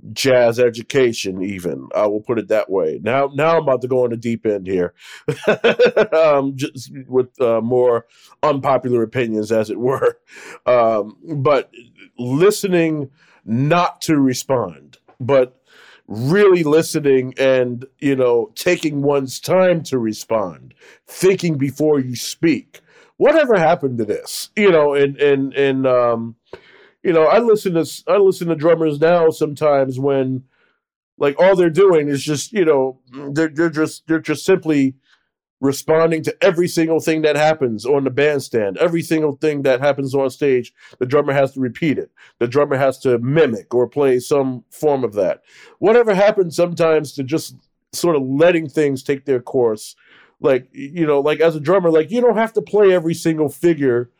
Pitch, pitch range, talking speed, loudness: 145 Hz, 130-165 Hz, 165 wpm, -17 LUFS